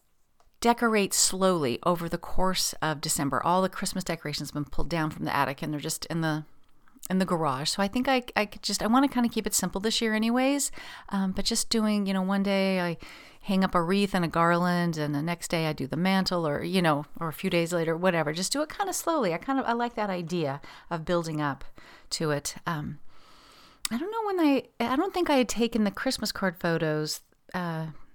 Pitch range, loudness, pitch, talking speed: 160-220 Hz, -27 LUFS, 185 Hz, 240 wpm